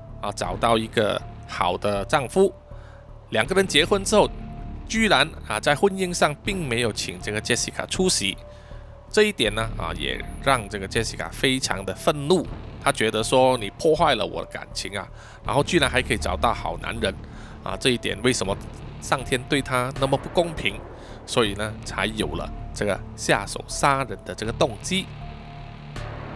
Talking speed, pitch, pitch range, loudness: 250 characters per minute, 115 Hz, 105-140 Hz, -23 LUFS